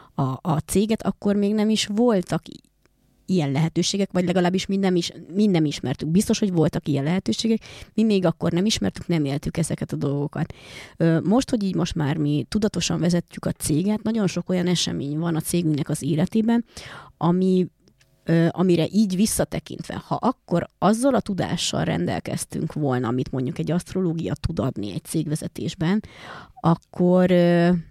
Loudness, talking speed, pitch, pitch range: -23 LUFS, 150 wpm, 175 Hz, 160-195 Hz